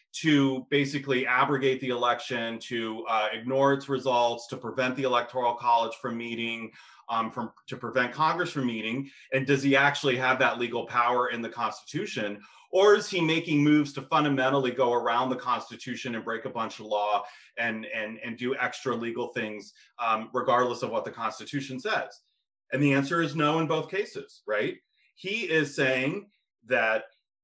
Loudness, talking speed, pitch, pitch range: -27 LUFS, 175 wpm, 130 Hz, 120-140 Hz